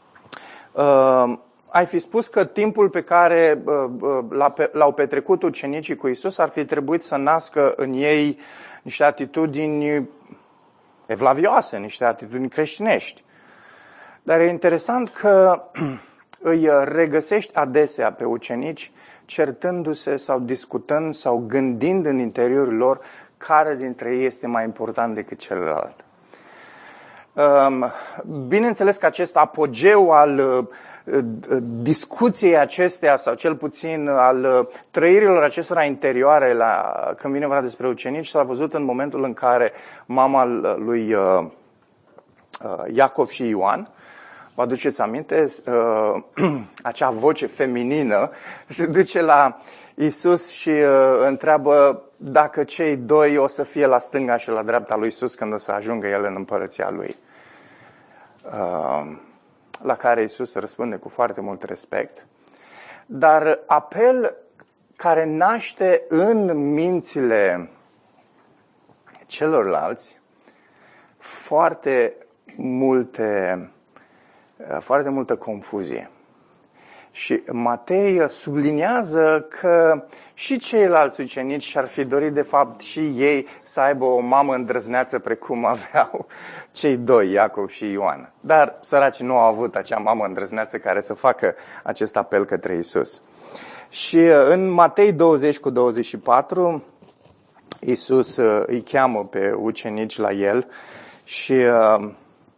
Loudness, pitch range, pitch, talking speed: -19 LUFS, 125-160 Hz, 145 Hz, 115 wpm